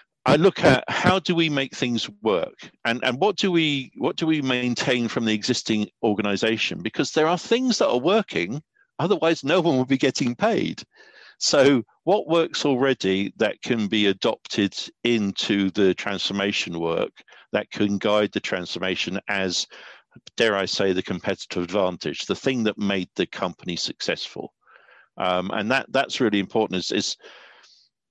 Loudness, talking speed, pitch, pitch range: -23 LUFS, 160 wpm, 115 Hz, 100-140 Hz